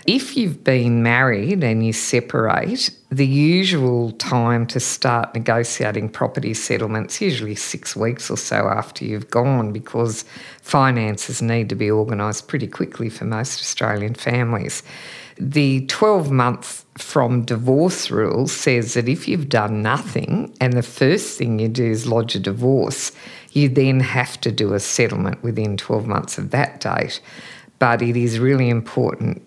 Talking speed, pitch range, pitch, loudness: 155 wpm, 110-135 Hz, 120 Hz, -19 LUFS